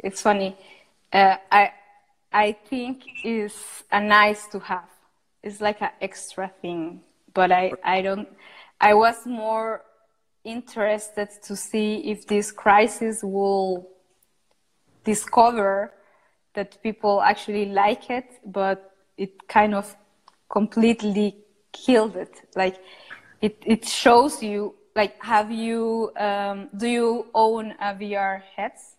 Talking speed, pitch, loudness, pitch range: 120 wpm, 210 Hz, -23 LUFS, 195-220 Hz